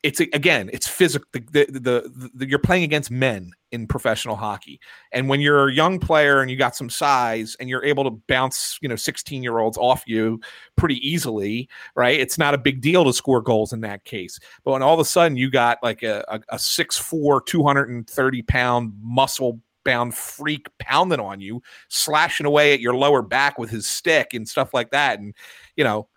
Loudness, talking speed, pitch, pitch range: -20 LUFS, 200 wpm, 130 Hz, 115-145 Hz